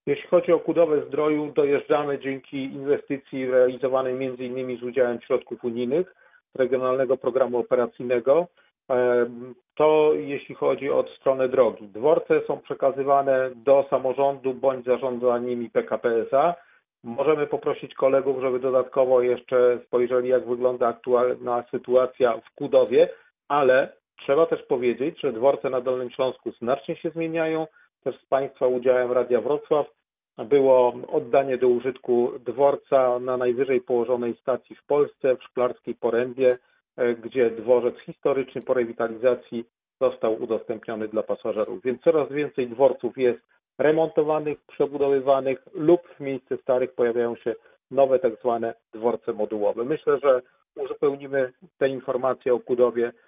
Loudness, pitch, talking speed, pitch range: -24 LUFS, 130 Hz, 125 wpm, 125-150 Hz